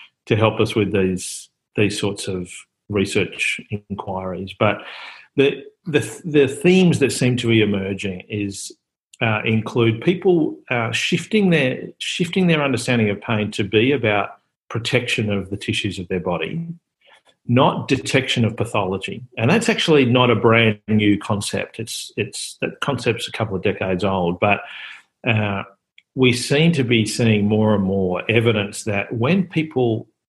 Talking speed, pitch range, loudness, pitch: 155 wpm, 100-135 Hz, -19 LUFS, 110 Hz